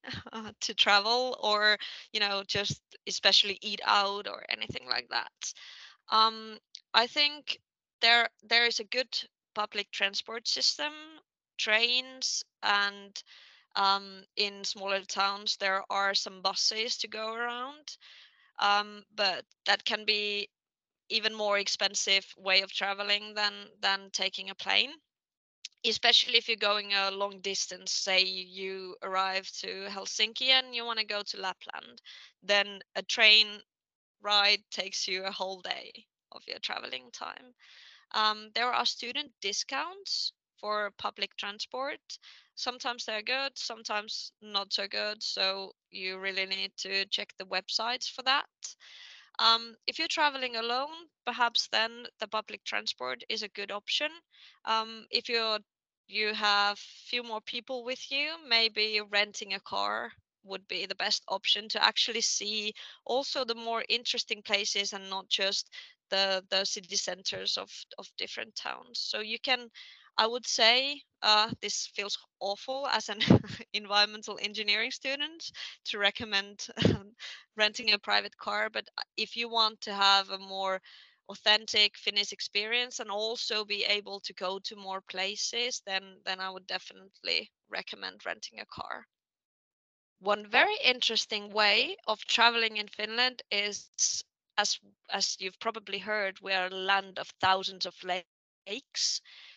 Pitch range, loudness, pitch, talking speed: 195-230 Hz, -29 LUFS, 210 Hz, 140 wpm